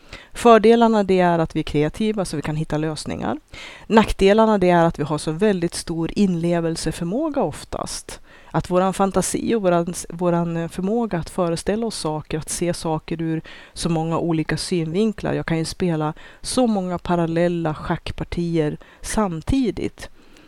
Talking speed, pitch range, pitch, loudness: 145 wpm, 160-195 Hz, 170 Hz, -21 LUFS